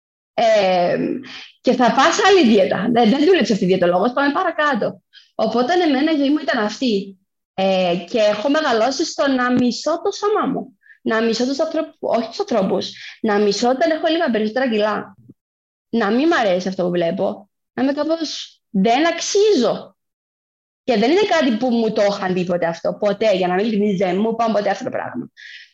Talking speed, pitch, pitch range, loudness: 180 wpm, 235 Hz, 205-315 Hz, -18 LUFS